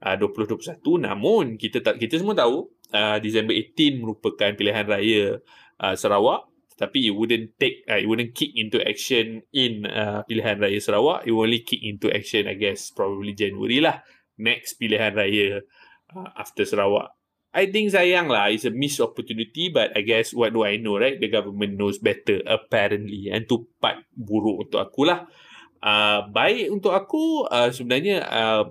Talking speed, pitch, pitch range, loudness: 175 wpm, 110 Hz, 105-140 Hz, -22 LUFS